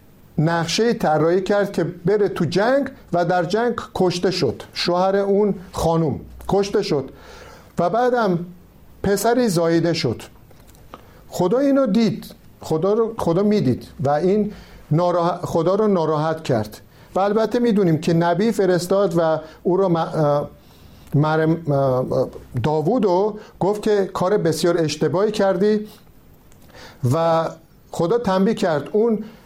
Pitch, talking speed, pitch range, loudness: 180 Hz, 120 wpm, 160-205 Hz, -20 LUFS